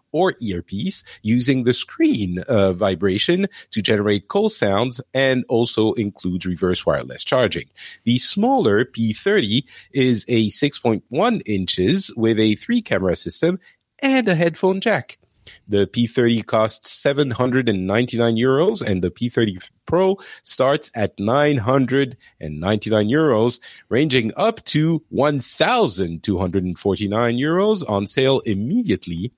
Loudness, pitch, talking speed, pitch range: -19 LUFS, 120 Hz, 110 wpm, 100-145 Hz